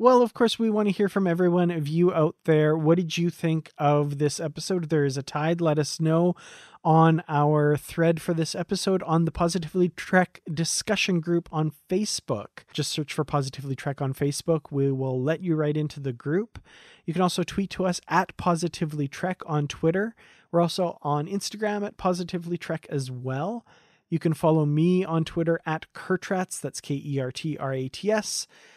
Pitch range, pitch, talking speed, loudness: 150-180 Hz, 165 Hz, 200 wpm, -26 LUFS